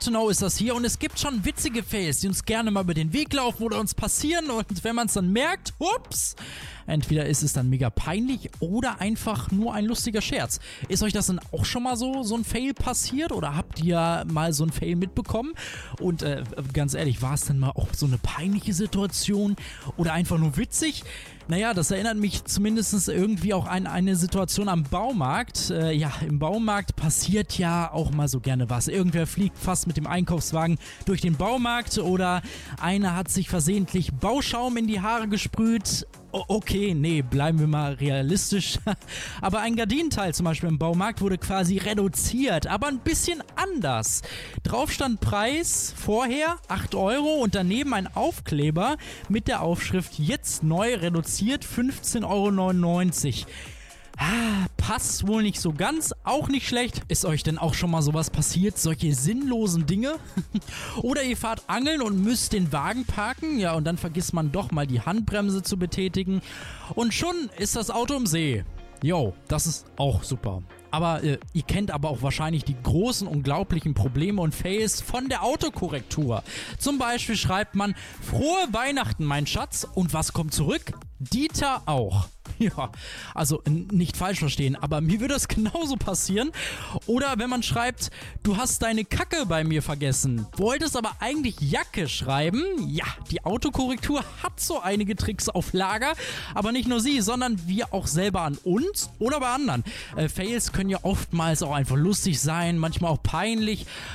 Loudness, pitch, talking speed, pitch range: -26 LUFS, 190 Hz, 175 wpm, 155-225 Hz